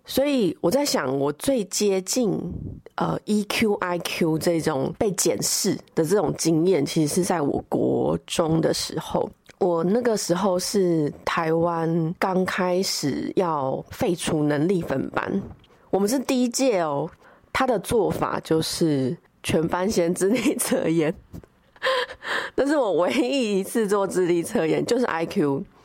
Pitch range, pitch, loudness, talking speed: 165-210 Hz, 180 Hz, -23 LUFS, 205 characters per minute